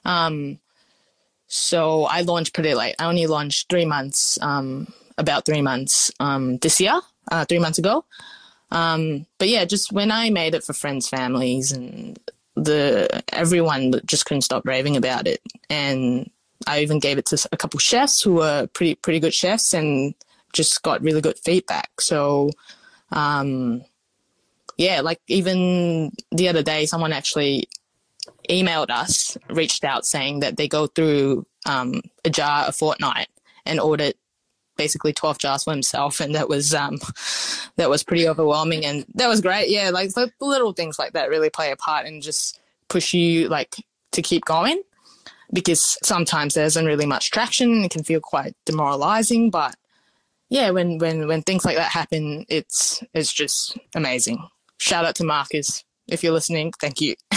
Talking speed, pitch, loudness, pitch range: 165 wpm, 160 Hz, -20 LUFS, 145-175 Hz